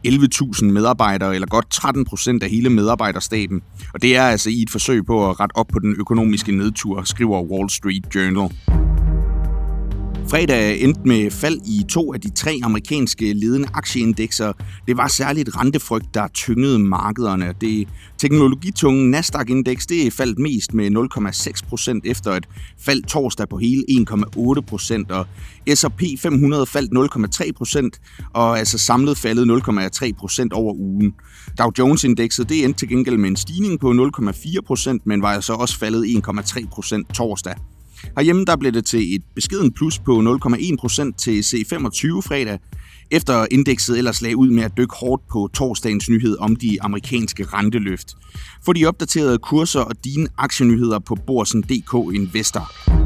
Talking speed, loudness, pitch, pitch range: 150 wpm, -18 LUFS, 115 Hz, 100-130 Hz